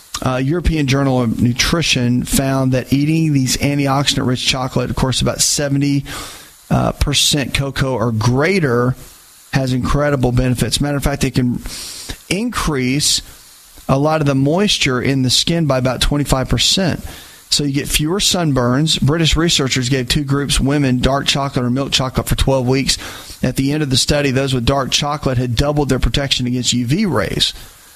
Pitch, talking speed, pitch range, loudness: 135 Hz, 165 wpm, 125-145 Hz, -16 LUFS